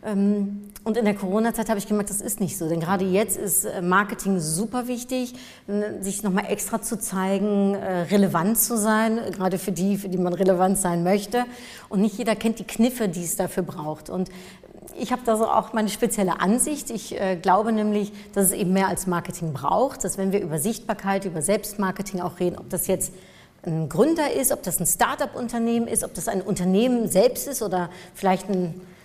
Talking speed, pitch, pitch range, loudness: 190 wpm, 200 Hz, 185-220 Hz, -24 LUFS